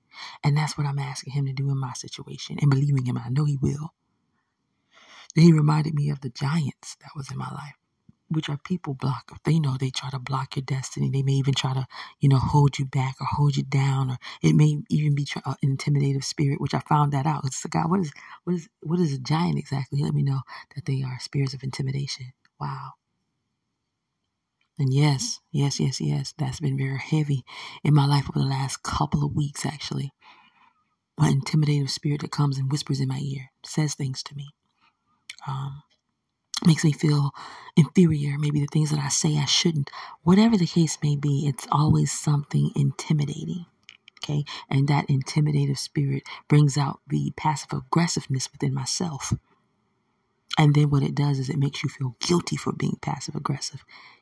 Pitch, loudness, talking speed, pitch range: 145 Hz, -25 LUFS, 190 wpm, 135-150 Hz